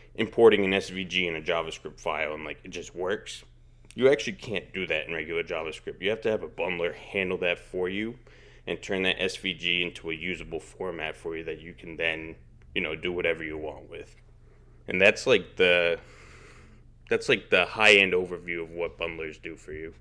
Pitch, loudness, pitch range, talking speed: 90 Hz, -27 LUFS, 80-95 Hz, 200 wpm